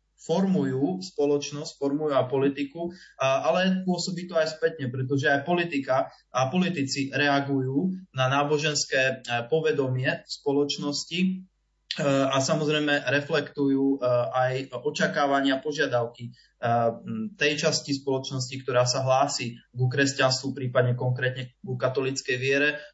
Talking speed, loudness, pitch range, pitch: 105 wpm, -26 LUFS, 130-155 Hz, 140 Hz